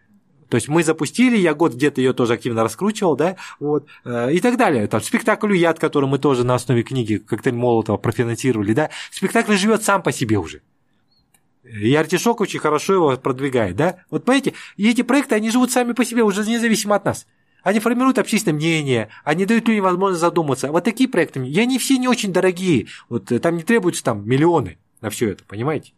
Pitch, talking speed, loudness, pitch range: 165 Hz, 195 wpm, -19 LUFS, 130-215 Hz